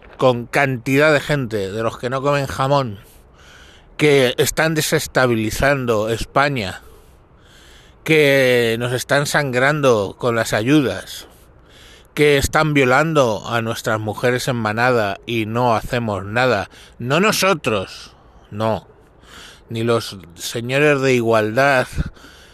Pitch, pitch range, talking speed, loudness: 125 Hz, 110-140 Hz, 110 wpm, -17 LUFS